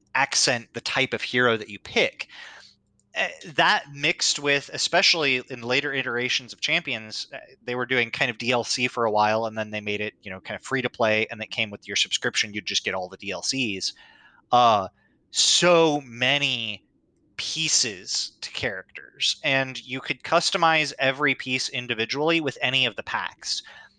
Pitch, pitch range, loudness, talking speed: 125 Hz, 110-145 Hz, -23 LUFS, 170 wpm